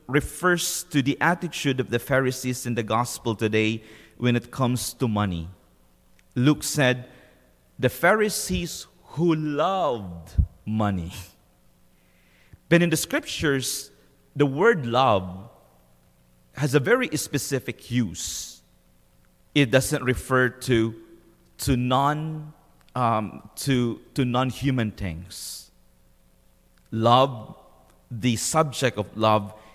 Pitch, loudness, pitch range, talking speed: 125 Hz, -24 LUFS, 100-140 Hz, 105 wpm